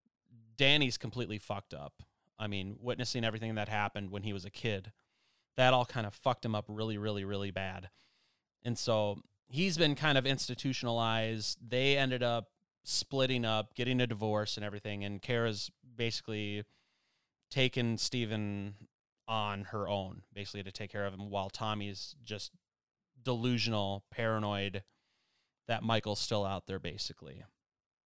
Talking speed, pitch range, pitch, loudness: 145 wpm, 100-125 Hz, 110 Hz, -35 LUFS